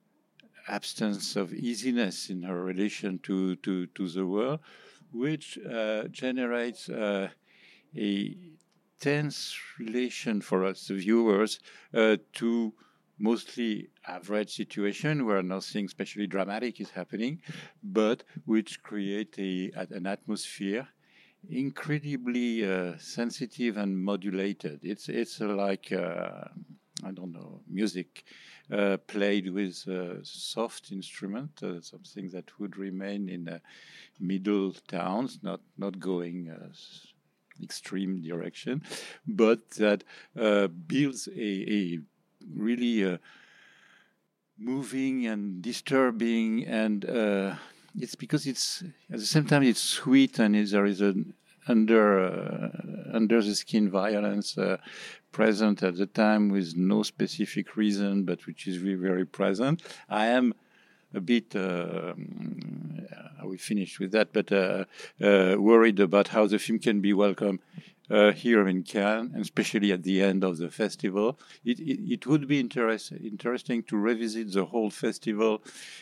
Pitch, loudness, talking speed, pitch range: 105 Hz, -29 LUFS, 130 wpm, 95-115 Hz